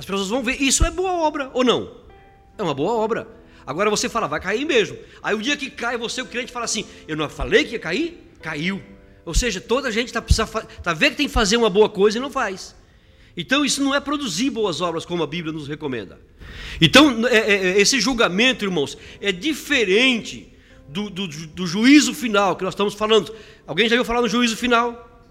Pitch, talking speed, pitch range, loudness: 220 Hz, 220 wpm, 185-255 Hz, -20 LUFS